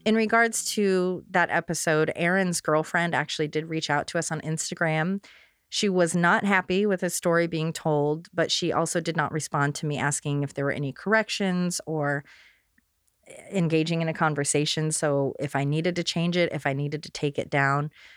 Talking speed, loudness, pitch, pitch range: 190 wpm, -25 LUFS, 160 Hz, 150-180 Hz